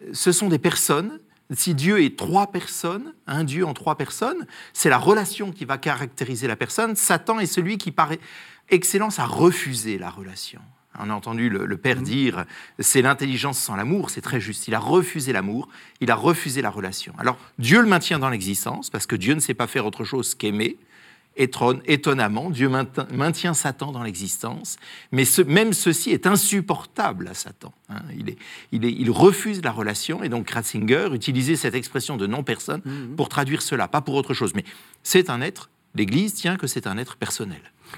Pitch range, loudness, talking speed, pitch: 120-175 Hz, -22 LUFS, 195 wpm, 140 Hz